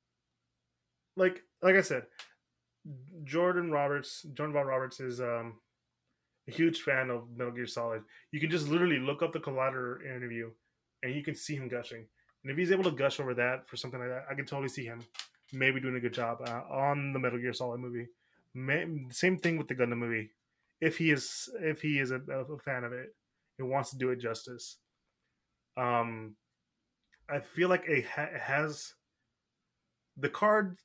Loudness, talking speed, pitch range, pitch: -33 LUFS, 185 wpm, 120-150 Hz, 130 Hz